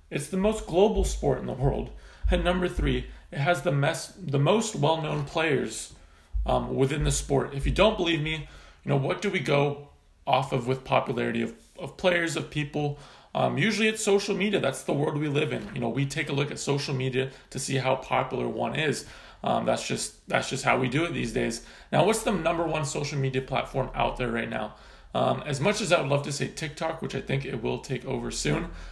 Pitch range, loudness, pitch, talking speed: 135-175 Hz, -27 LUFS, 145 Hz, 230 wpm